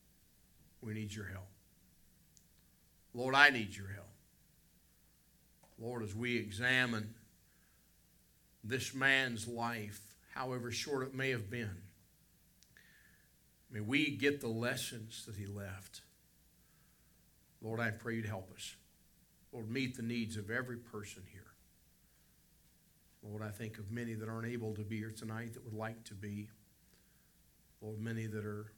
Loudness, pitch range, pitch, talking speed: -38 LUFS, 105-120 Hz, 110 Hz, 135 wpm